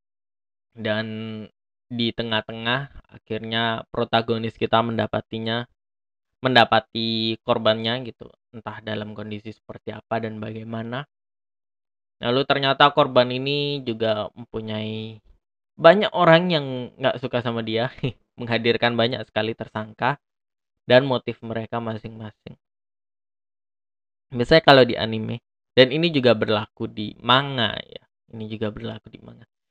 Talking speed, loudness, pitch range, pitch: 110 wpm, -22 LUFS, 110-120 Hz, 115 Hz